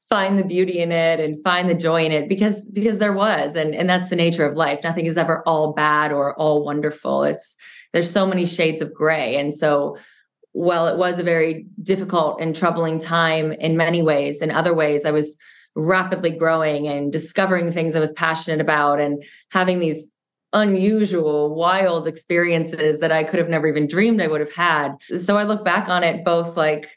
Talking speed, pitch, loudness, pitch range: 200 wpm, 165 Hz, -19 LUFS, 155-180 Hz